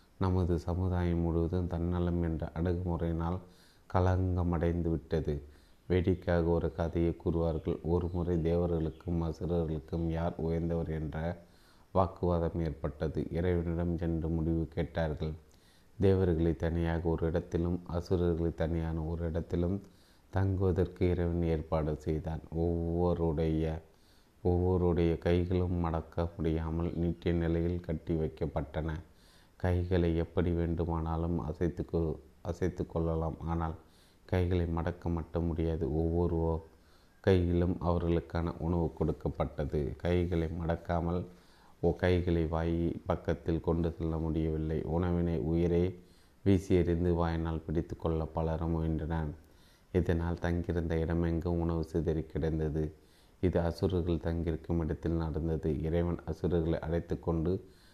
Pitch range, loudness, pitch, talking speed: 80-85 Hz, -33 LUFS, 85 Hz, 95 wpm